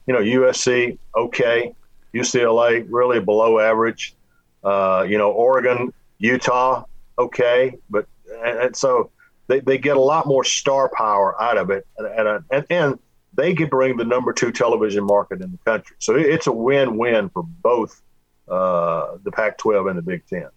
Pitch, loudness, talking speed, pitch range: 125 Hz, -19 LUFS, 170 wpm, 105-130 Hz